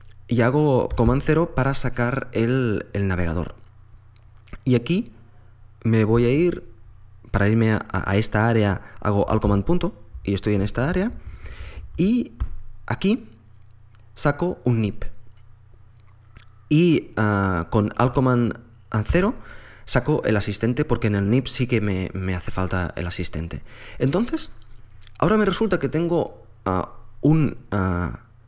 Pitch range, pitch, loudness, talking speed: 105-125 Hz, 110 Hz, -22 LUFS, 135 wpm